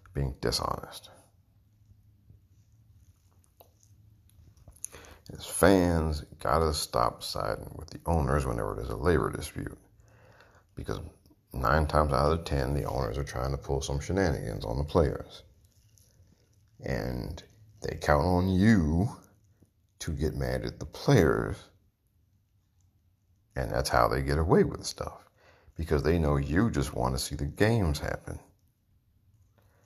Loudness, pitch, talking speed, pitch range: -29 LUFS, 95 Hz, 125 wpm, 75-100 Hz